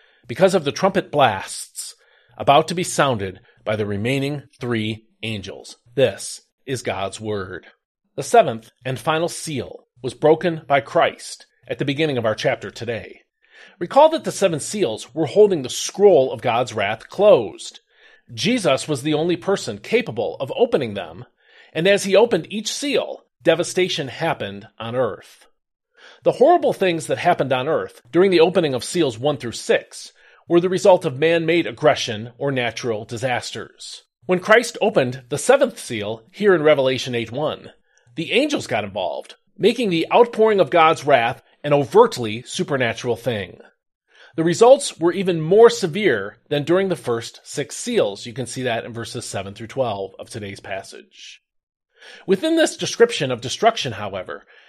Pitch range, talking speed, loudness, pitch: 120-185 Hz, 160 wpm, -19 LUFS, 155 Hz